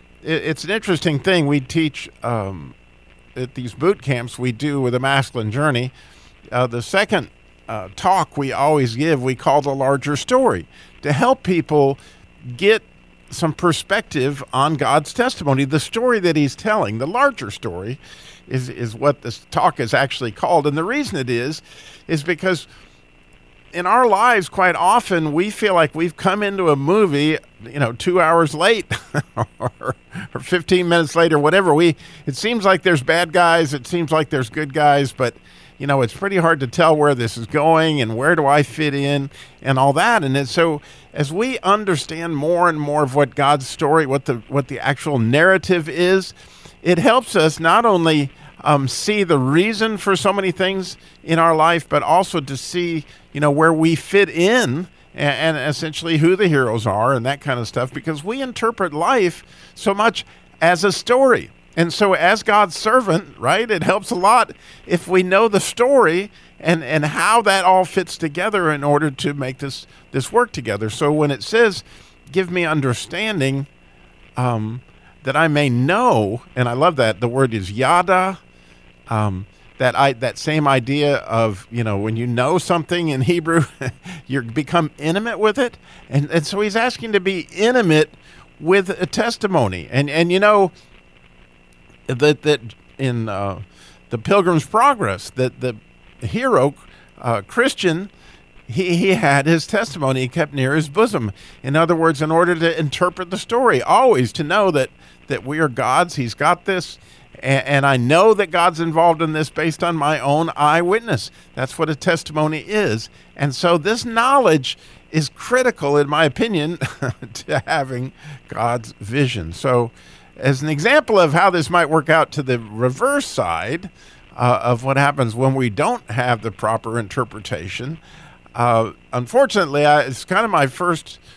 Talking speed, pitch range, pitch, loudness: 170 wpm, 130-175 Hz, 150 Hz, -18 LUFS